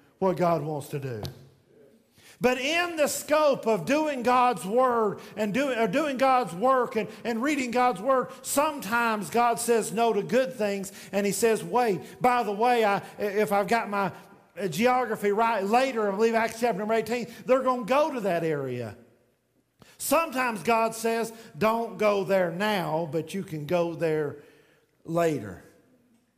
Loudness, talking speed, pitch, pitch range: -26 LUFS, 165 wpm, 225 Hz, 195-250 Hz